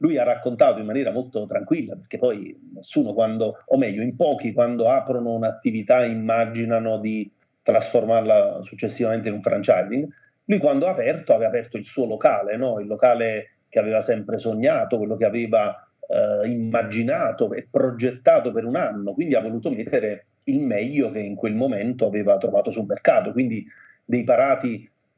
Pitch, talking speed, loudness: 115 Hz, 160 wpm, -22 LUFS